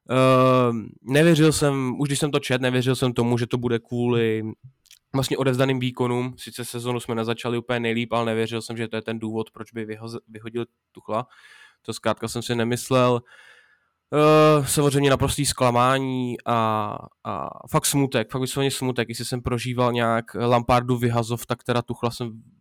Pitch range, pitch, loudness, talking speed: 115-130 Hz, 120 Hz, -23 LUFS, 165 wpm